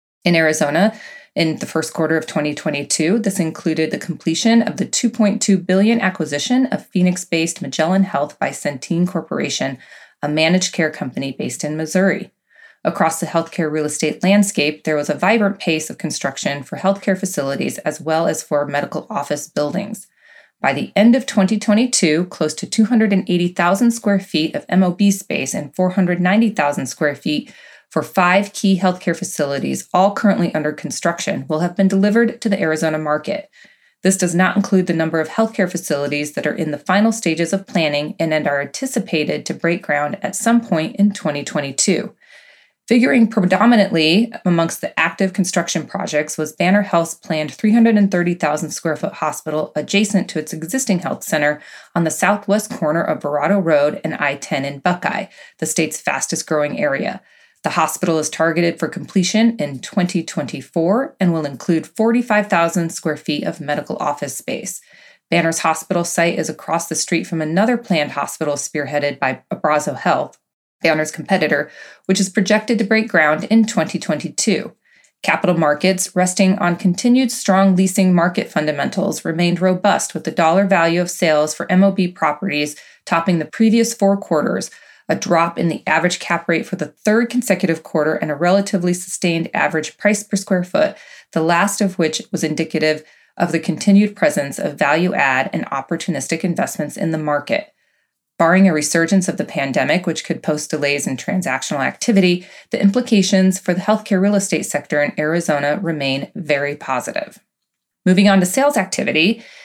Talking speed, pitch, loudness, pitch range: 160 wpm, 175 Hz, -18 LUFS, 155-200 Hz